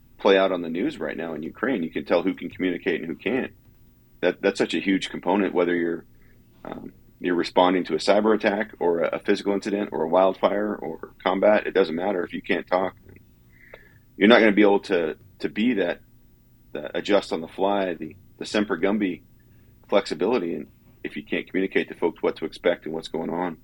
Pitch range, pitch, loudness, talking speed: 85-100 Hz, 95 Hz, -24 LUFS, 210 wpm